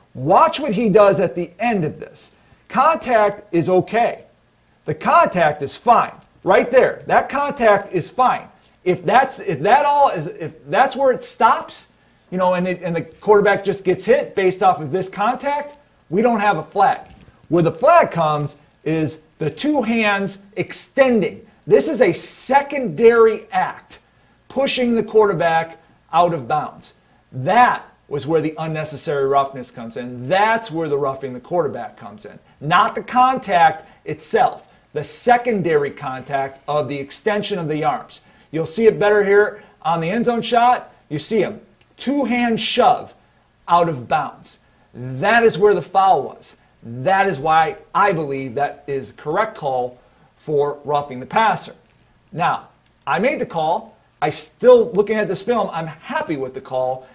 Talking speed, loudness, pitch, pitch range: 165 wpm, -18 LUFS, 195 Hz, 155-235 Hz